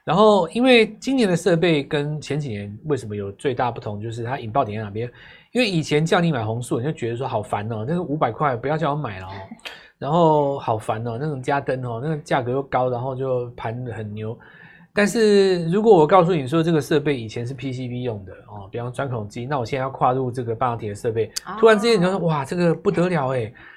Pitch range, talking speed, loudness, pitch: 120-170 Hz, 345 characters per minute, -21 LUFS, 140 Hz